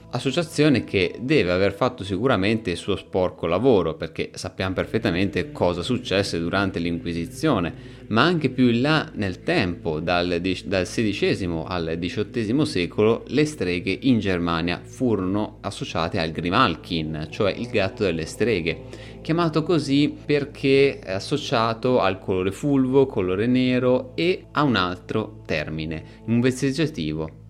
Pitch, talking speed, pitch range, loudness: 105 Hz, 130 wpm, 90-130 Hz, -23 LUFS